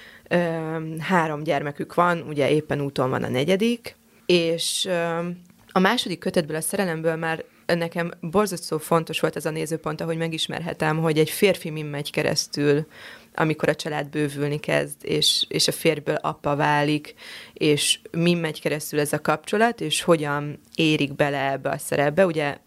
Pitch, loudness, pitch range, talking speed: 160 Hz, -23 LUFS, 150-170 Hz, 150 wpm